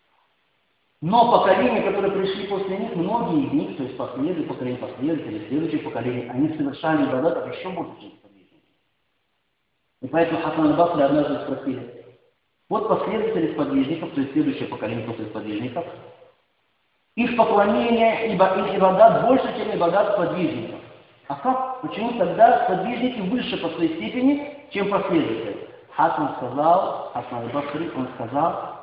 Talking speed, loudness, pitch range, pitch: 135 wpm, -22 LUFS, 150-235 Hz, 190 Hz